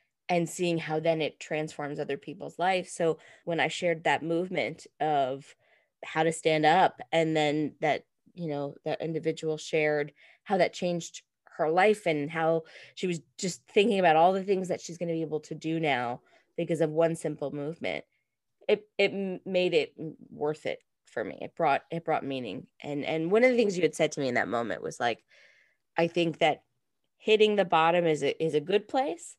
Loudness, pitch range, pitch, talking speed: -29 LUFS, 155-180 Hz, 165 Hz, 200 wpm